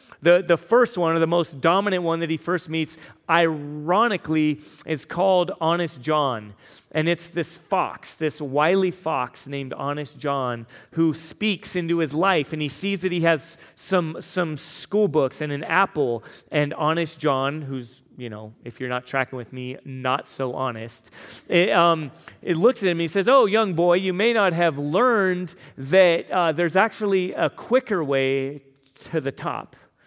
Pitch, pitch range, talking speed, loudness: 160 Hz, 140-180 Hz, 175 wpm, -22 LUFS